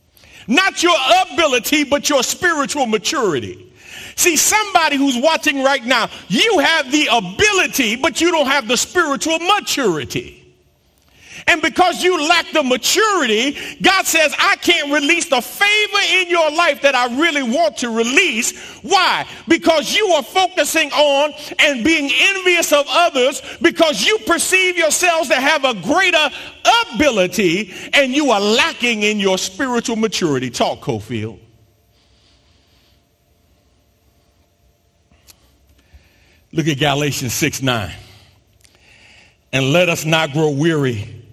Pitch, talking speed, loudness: 280 Hz, 125 wpm, -15 LUFS